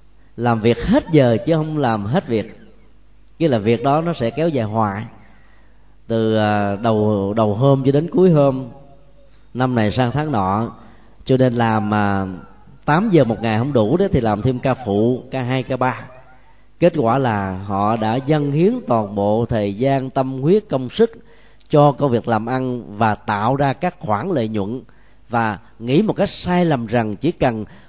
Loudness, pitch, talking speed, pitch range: -18 LUFS, 125 Hz, 185 wpm, 110-140 Hz